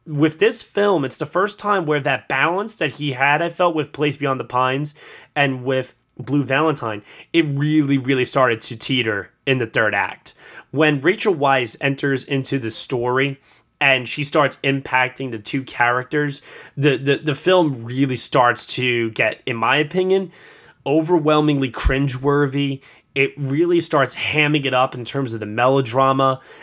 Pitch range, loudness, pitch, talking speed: 130-150 Hz, -19 LUFS, 140 Hz, 165 wpm